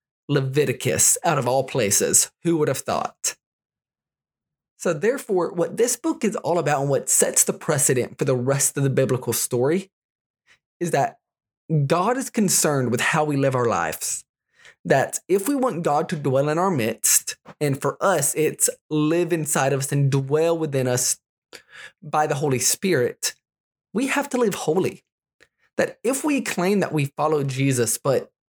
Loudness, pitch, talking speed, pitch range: -21 LUFS, 155 Hz, 170 wpm, 135-195 Hz